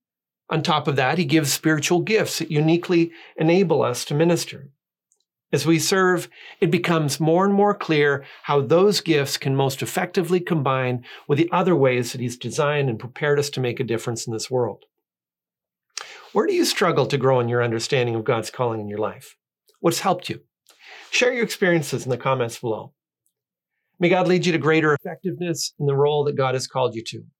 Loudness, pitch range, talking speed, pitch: -21 LUFS, 130-175 Hz, 195 wpm, 150 Hz